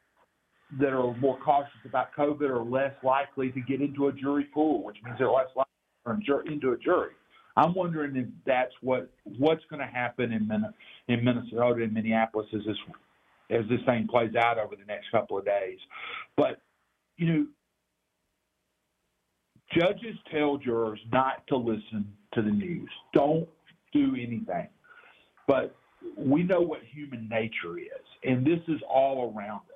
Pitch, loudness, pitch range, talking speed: 135 Hz, -29 LUFS, 120-155 Hz, 160 wpm